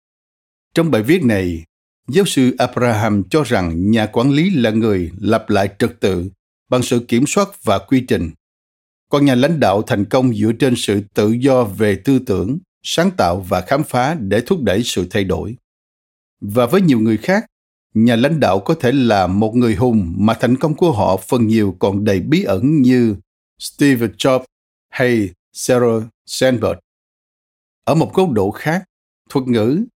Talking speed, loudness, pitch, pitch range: 175 wpm, -16 LUFS, 115 Hz, 100-130 Hz